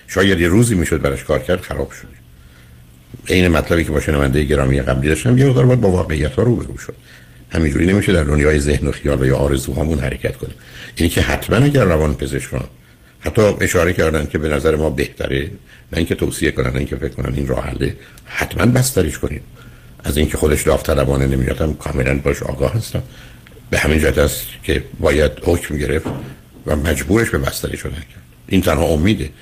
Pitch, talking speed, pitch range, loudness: 75 Hz, 180 wpm, 70-85 Hz, -17 LUFS